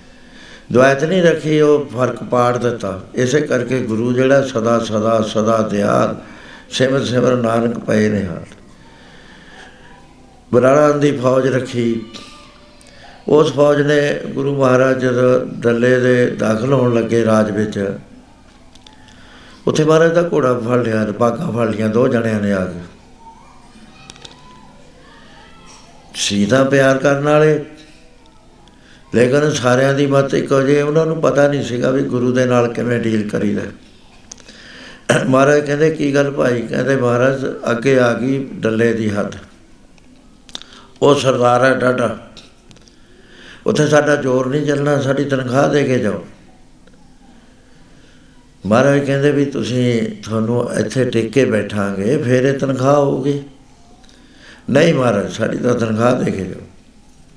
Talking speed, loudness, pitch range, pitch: 125 wpm, -15 LUFS, 115-140 Hz, 125 Hz